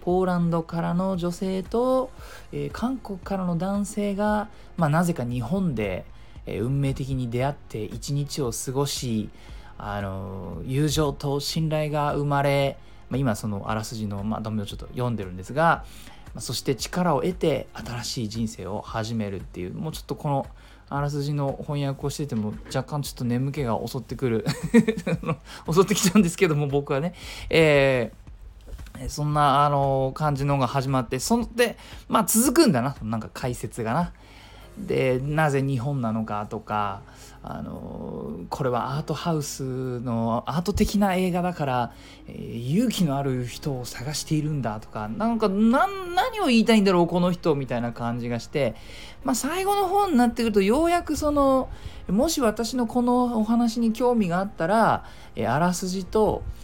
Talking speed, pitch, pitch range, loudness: 320 characters per minute, 145 Hz, 120-190 Hz, -25 LUFS